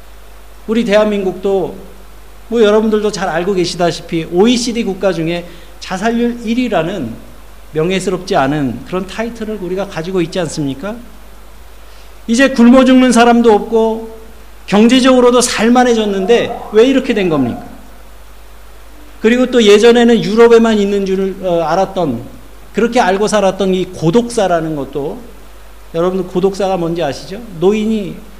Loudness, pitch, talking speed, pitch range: -12 LUFS, 205 Hz, 300 characters per minute, 180-230 Hz